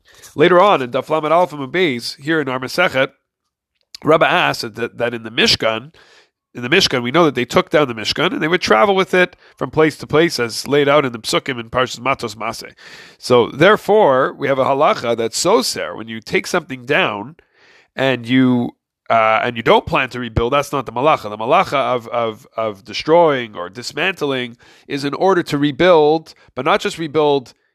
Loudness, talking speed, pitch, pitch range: -16 LUFS, 200 wpm, 135 Hz, 120-155 Hz